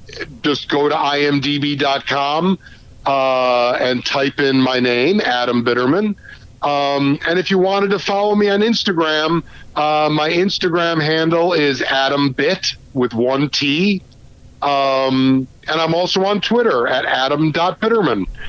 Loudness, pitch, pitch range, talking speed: -16 LUFS, 145 Hz, 135-175 Hz, 130 wpm